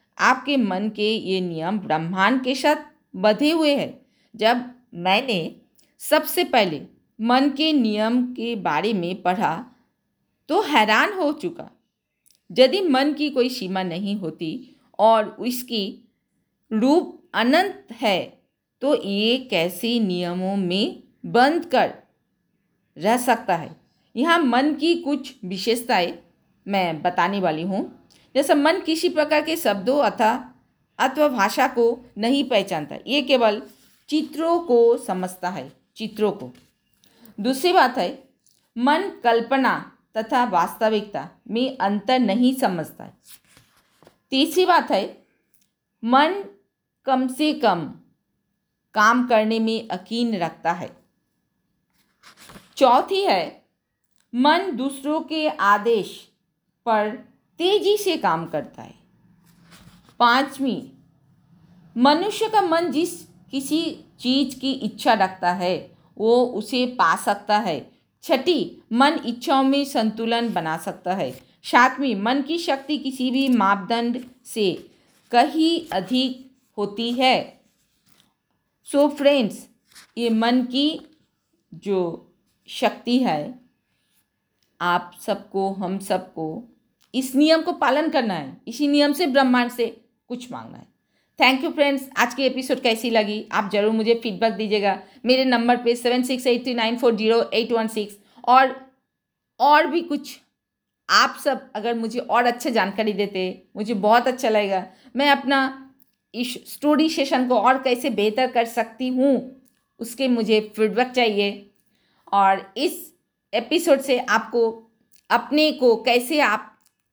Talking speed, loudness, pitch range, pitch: 125 wpm, -21 LUFS, 210-275 Hz, 240 Hz